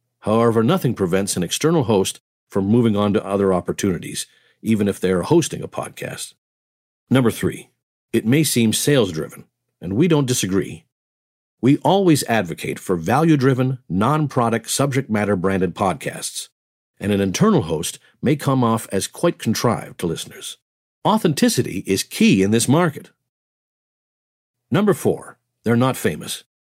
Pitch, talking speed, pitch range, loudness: 115 Hz, 145 wpm, 95-130 Hz, -19 LUFS